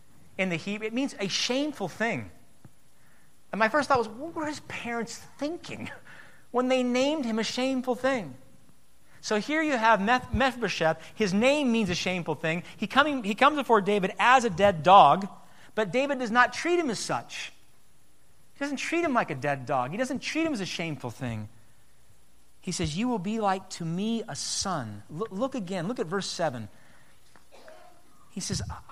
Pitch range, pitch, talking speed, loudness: 175-260 Hz, 220 Hz, 190 wpm, -27 LUFS